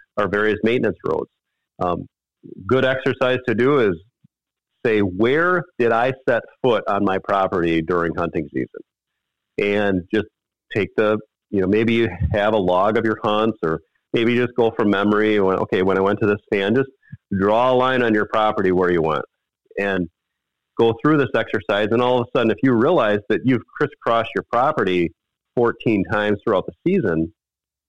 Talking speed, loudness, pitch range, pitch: 175 wpm, -20 LUFS, 95-115 Hz, 105 Hz